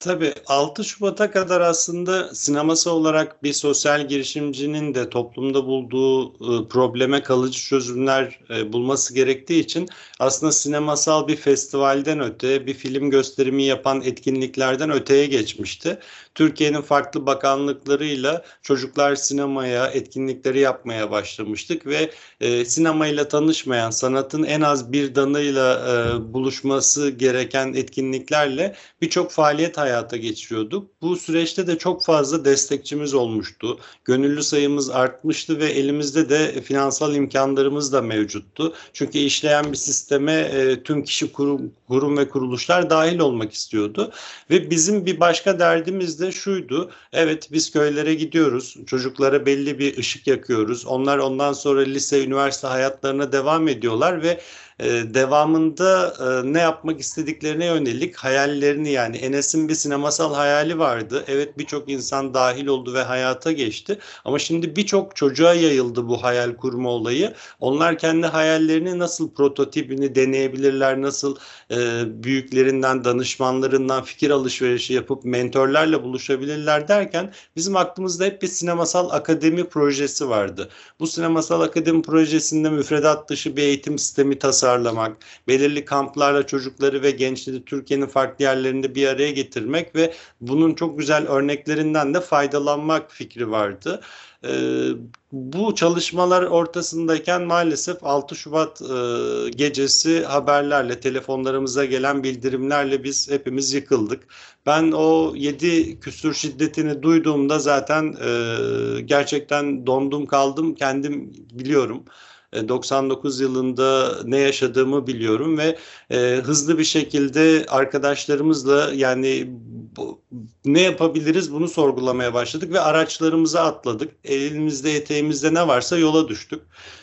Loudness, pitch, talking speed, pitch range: -20 LUFS, 140 Hz, 120 wpm, 130-155 Hz